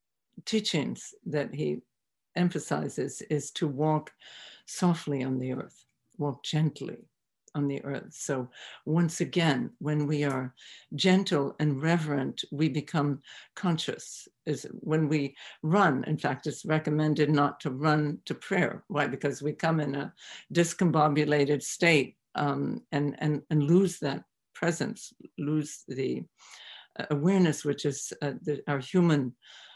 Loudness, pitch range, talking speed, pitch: -29 LUFS, 145-165 Hz, 125 wpm, 150 Hz